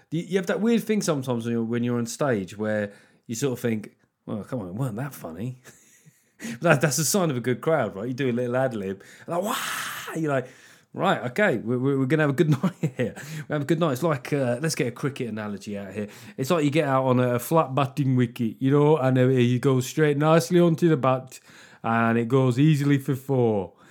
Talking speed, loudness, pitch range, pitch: 225 wpm, -24 LUFS, 120-155 Hz, 130 Hz